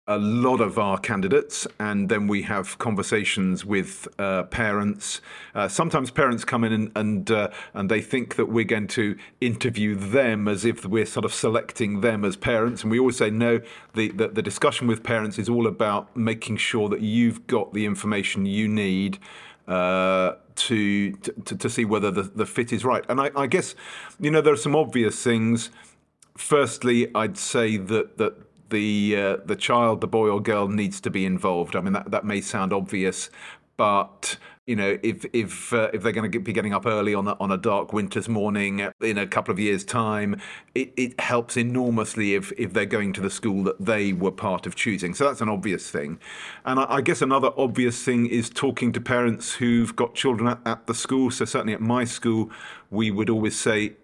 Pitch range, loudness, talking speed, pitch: 105-120 Hz, -24 LUFS, 205 wpm, 110 Hz